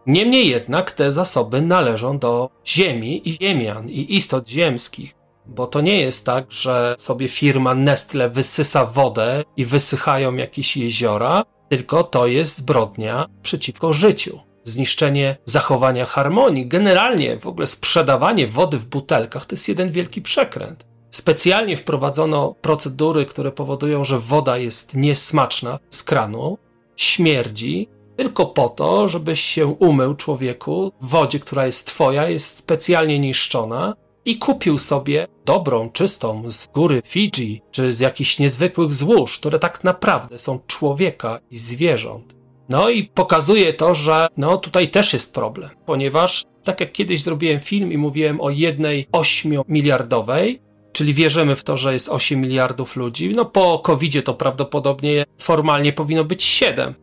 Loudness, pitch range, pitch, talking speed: -18 LUFS, 130-165 Hz, 145 Hz, 140 wpm